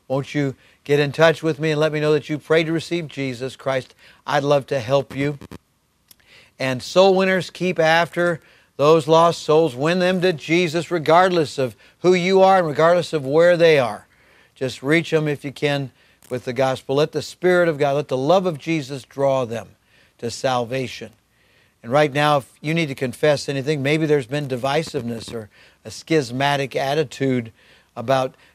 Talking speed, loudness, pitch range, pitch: 185 wpm, -19 LUFS, 130-165 Hz, 145 Hz